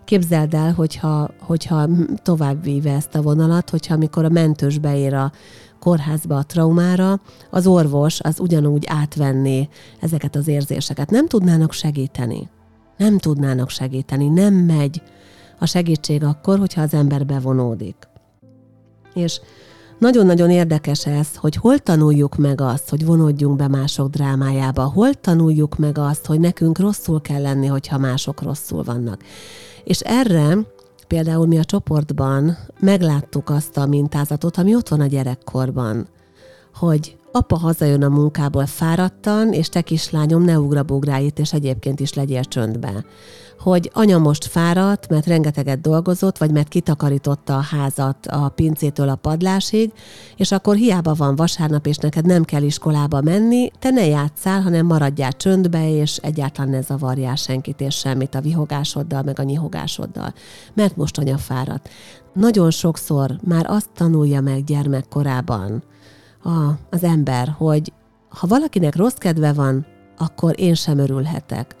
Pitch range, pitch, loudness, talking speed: 135-170 Hz, 150 Hz, -18 LUFS, 140 wpm